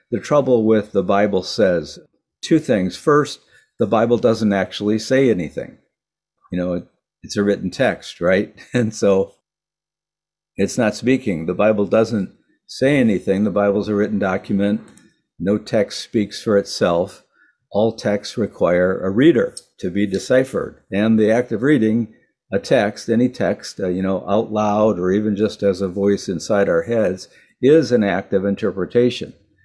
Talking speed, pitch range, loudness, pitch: 160 wpm, 95-110 Hz, -19 LUFS, 105 Hz